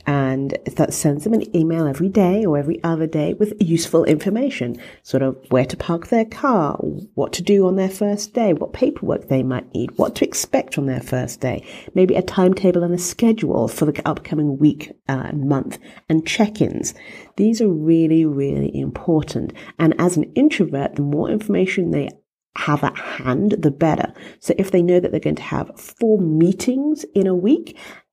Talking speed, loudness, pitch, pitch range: 190 wpm, -19 LUFS, 170 Hz, 150-200 Hz